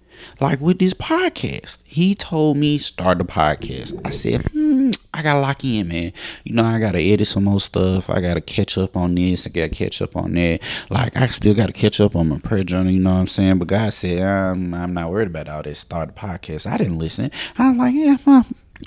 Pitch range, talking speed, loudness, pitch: 90-140 Hz, 235 wpm, -19 LUFS, 100 Hz